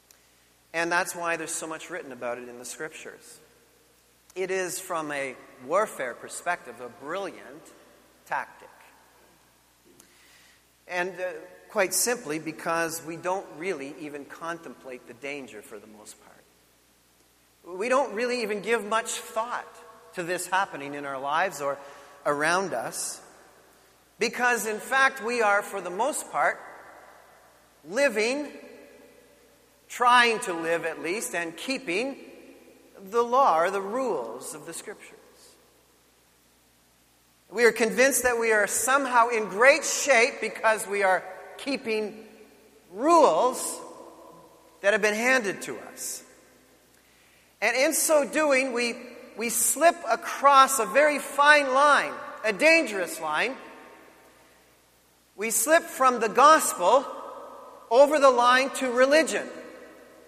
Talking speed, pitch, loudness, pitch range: 125 wpm, 215 Hz, -24 LUFS, 165-260 Hz